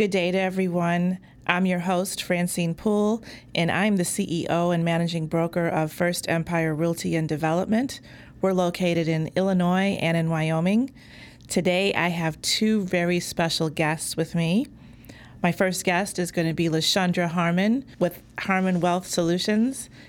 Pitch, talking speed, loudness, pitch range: 175 Hz, 150 wpm, -24 LUFS, 165-185 Hz